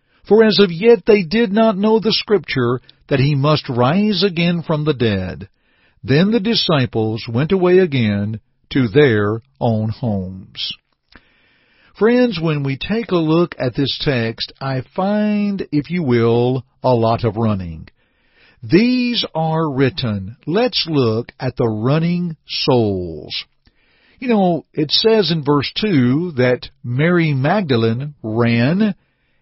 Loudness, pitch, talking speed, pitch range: -17 LUFS, 145 Hz, 135 wpm, 120-185 Hz